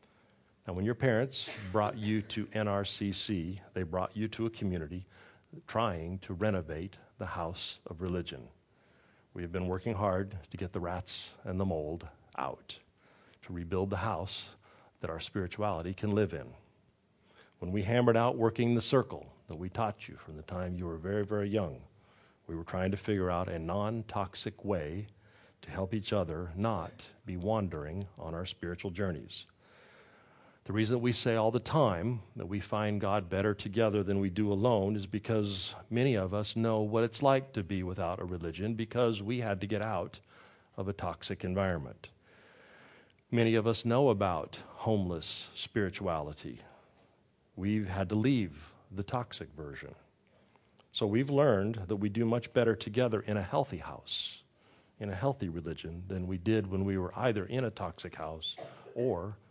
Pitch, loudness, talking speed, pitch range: 100 Hz, -34 LUFS, 170 wpm, 90-110 Hz